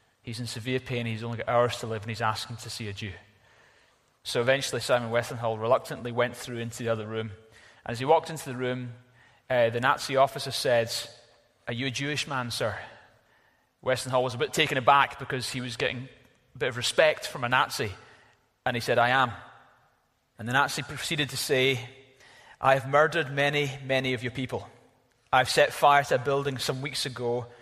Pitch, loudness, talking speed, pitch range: 125 Hz, -27 LUFS, 200 wpm, 120-135 Hz